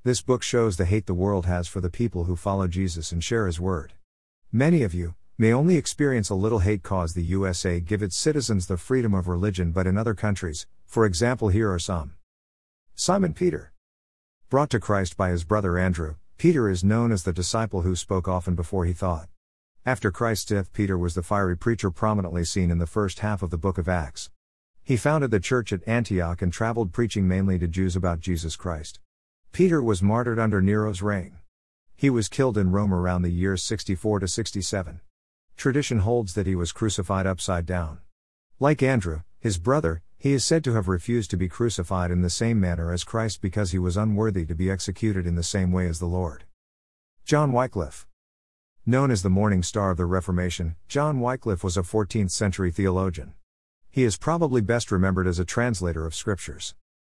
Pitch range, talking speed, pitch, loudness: 90-110 Hz, 195 wpm, 95 Hz, -25 LUFS